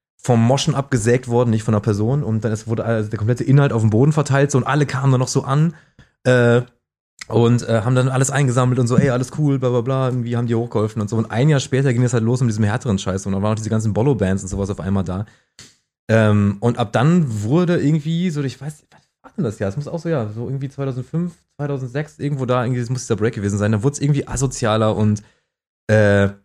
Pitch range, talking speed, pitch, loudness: 110-140 Hz, 255 wpm, 125 Hz, -19 LUFS